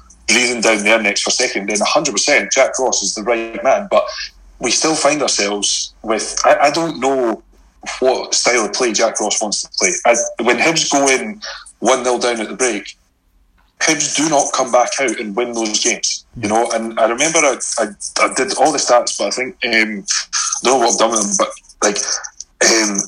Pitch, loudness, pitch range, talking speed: 115 Hz, -15 LUFS, 105-130 Hz, 210 wpm